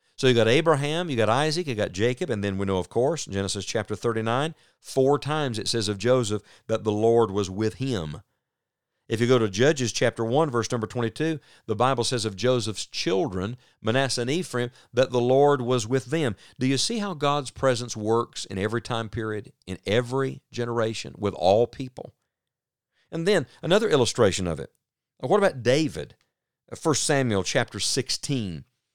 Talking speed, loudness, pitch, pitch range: 180 wpm, -25 LUFS, 120 Hz, 110-135 Hz